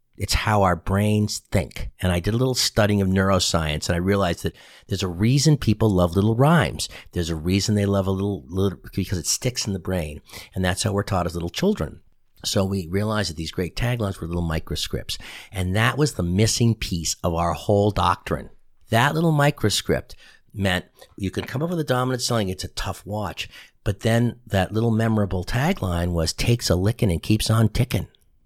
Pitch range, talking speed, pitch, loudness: 90-110 Hz, 200 wpm, 100 Hz, -23 LUFS